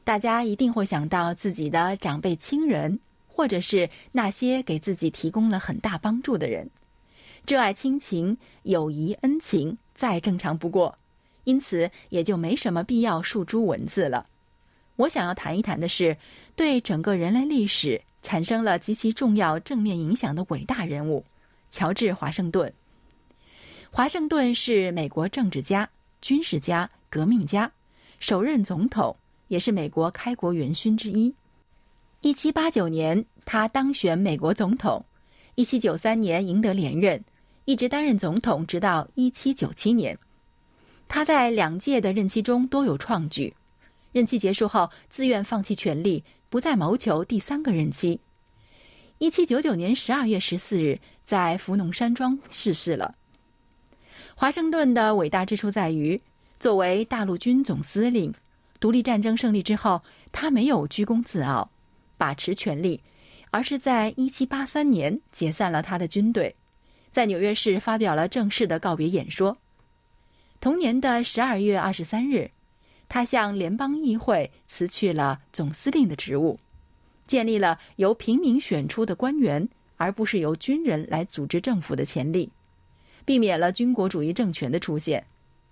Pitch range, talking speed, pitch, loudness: 175-245 Hz, 235 characters per minute, 210 Hz, -25 LUFS